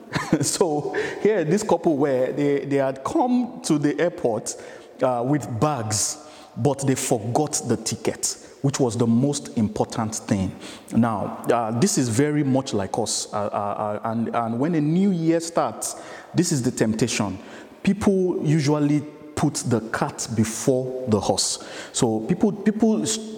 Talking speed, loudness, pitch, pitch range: 150 wpm, -23 LUFS, 145 Hz, 120-170 Hz